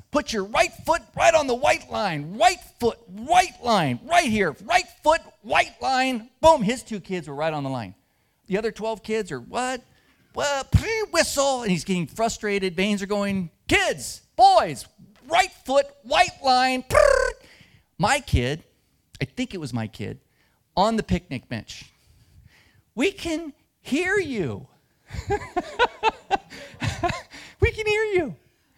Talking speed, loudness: 150 wpm, -23 LUFS